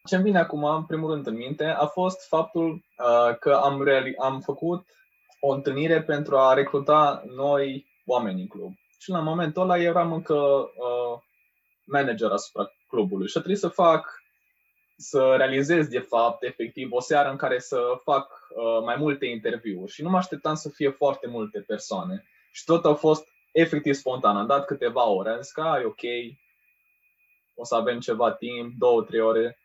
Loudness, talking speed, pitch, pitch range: -24 LUFS, 175 wpm, 145 Hz, 130-165 Hz